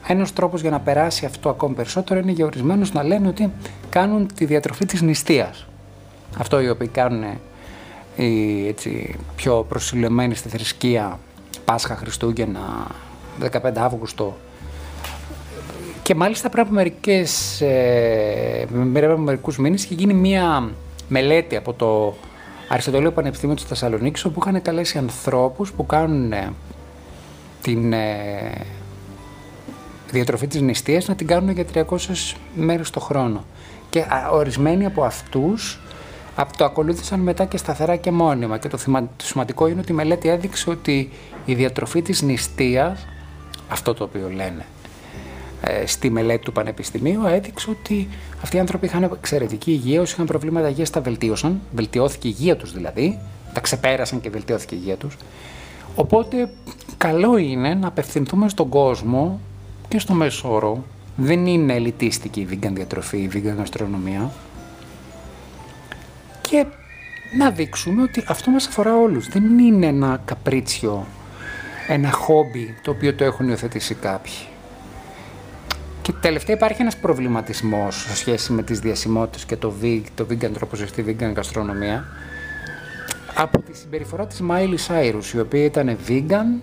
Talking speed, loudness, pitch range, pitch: 135 wpm, -21 LUFS, 105-165 Hz, 130 Hz